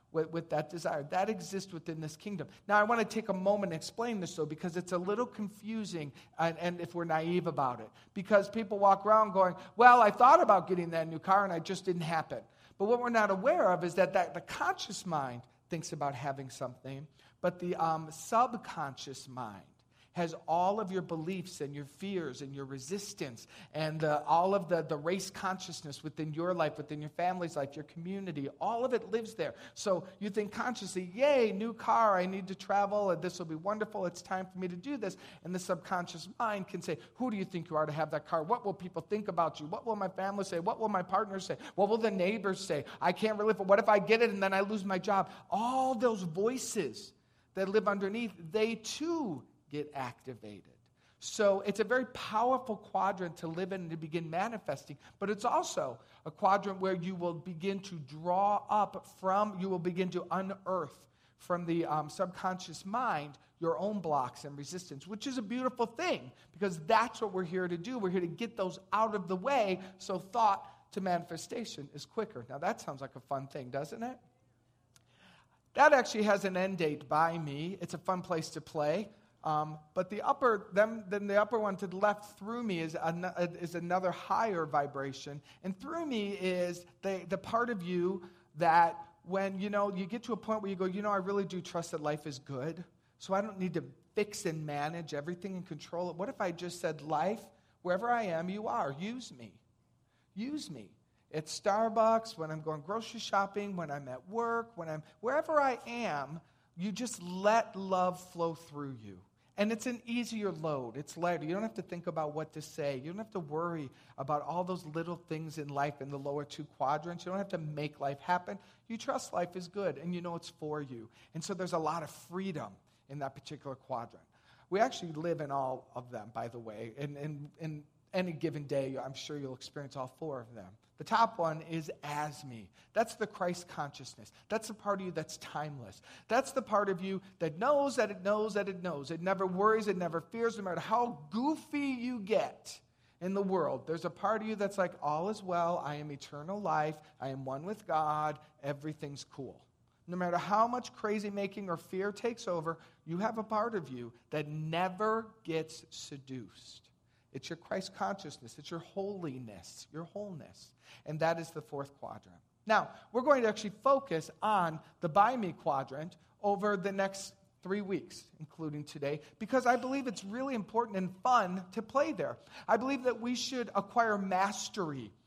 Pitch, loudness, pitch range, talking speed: 180 Hz, -34 LUFS, 155-205 Hz, 205 wpm